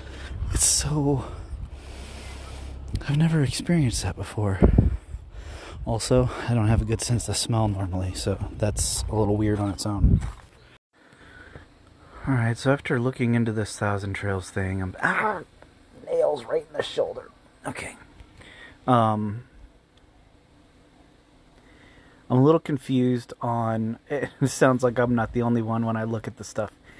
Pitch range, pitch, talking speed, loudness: 95-125 Hz, 110 Hz, 140 wpm, -25 LUFS